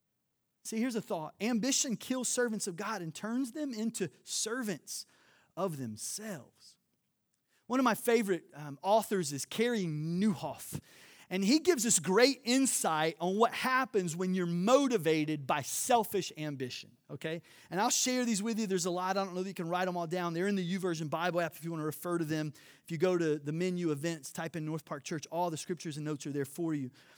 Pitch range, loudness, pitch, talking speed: 160-220 Hz, -33 LUFS, 180 Hz, 210 wpm